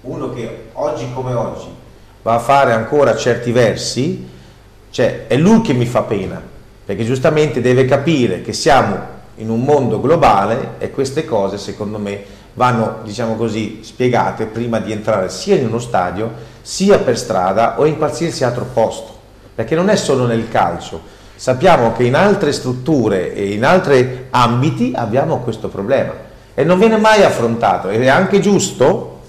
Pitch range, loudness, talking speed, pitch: 110-140 Hz, -15 LUFS, 160 wpm, 120 Hz